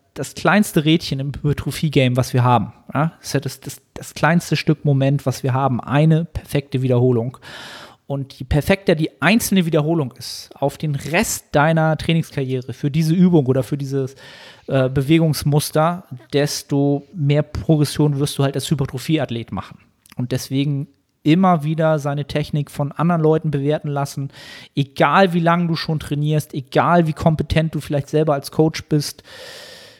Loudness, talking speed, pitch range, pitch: -19 LUFS, 155 wpm, 135-160 Hz, 145 Hz